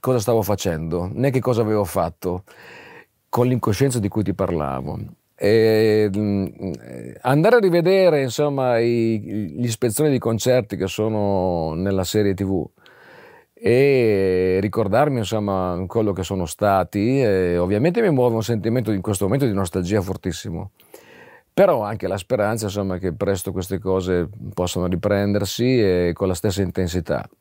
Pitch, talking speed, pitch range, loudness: 100 Hz, 140 wpm, 95-115 Hz, -20 LUFS